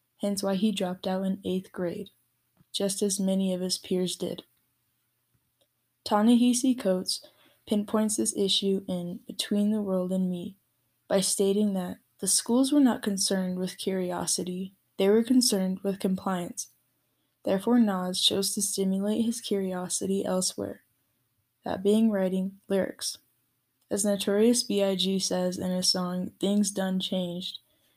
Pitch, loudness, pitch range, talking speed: 190 Hz, -27 LUFS, 180-205 Hz, 135 wpm